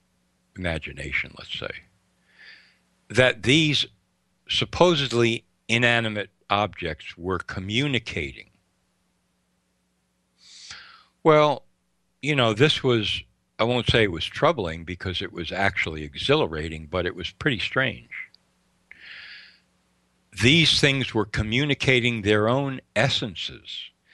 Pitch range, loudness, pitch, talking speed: 80-125 Hz, -23 LUFS, 105 Hz, 95 wpm